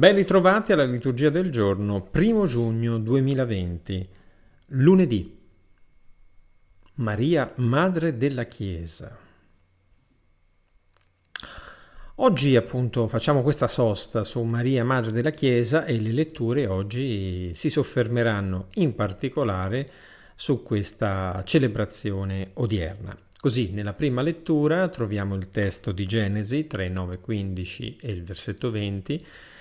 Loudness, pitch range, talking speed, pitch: -24 LUFS, 95-135 Hz, 105 wpm, 115 Hz